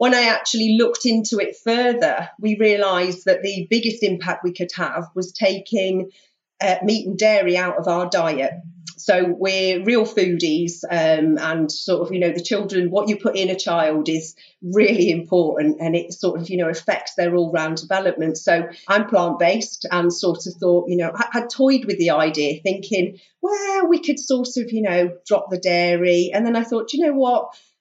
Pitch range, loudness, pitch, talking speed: 175-215 Hz, -19 LUFS, 185 Hz, 200 wpm